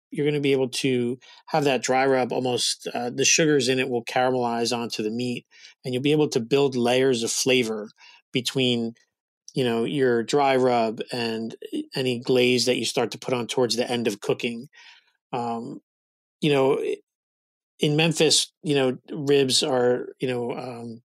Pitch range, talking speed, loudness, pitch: 120-135 Hz, 175 wpm, -23 LUFS, 125 Hz